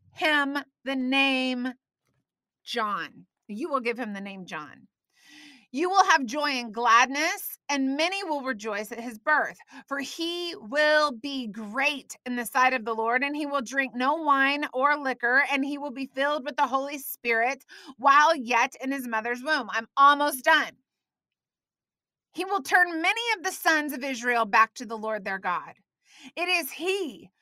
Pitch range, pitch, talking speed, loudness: 245-300 Hz, 275 Hz, 175 wpm, -25 LUFS